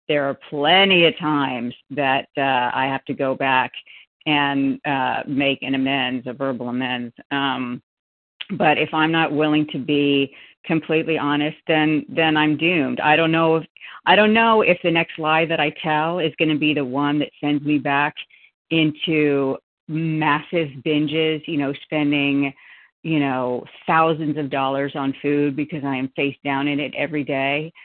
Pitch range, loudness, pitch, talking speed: 140-155 Hz, -20 LUFS, 145 Hz, 170 wpm